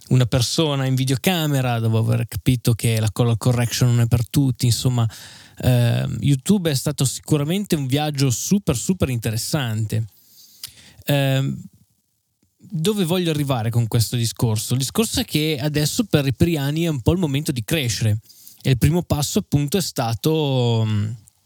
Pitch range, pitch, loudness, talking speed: 115-150 Hz, 130 Hz, -20 LUFS, 155 wpm